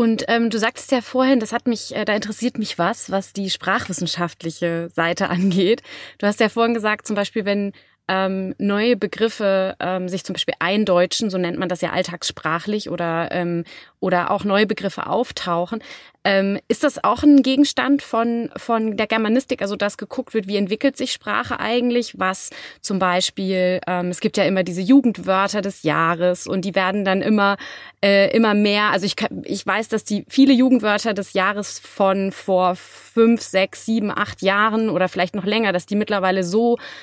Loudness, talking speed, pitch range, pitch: -20 LUFS, 180 wpm, 185-225 Hz, 205 Hz